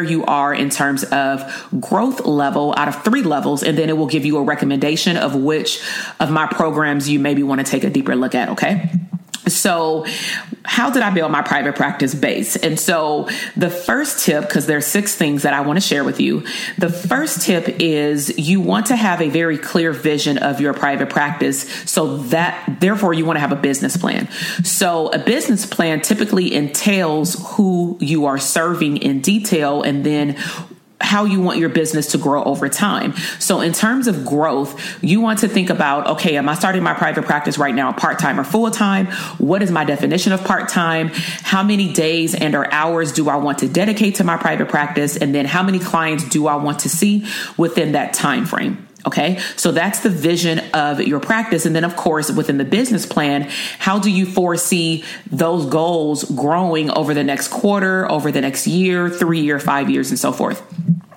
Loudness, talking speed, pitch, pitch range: -17 LUFS, 200 wpm, 165 Hz, 150-195 Hz